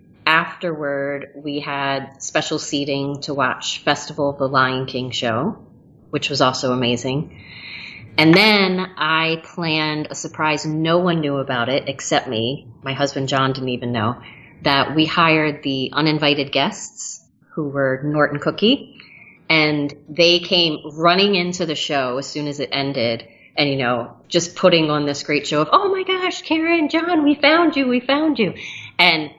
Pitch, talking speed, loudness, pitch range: 150 Hz, 165 wpm, -19 LUFS, 135-170 Hz